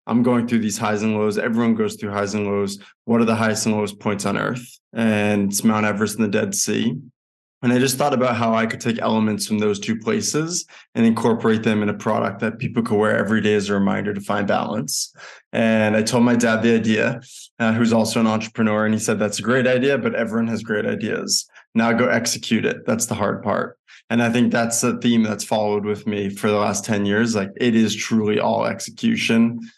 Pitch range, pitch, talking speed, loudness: 105-125 Hz, 115 Hz, 230 wpm, -20 LUFS